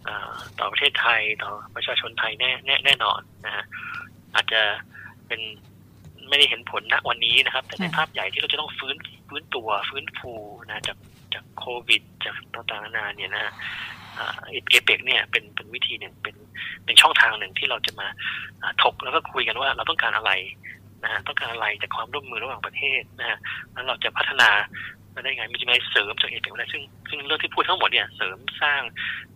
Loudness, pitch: -22 LUFS, 115 Hz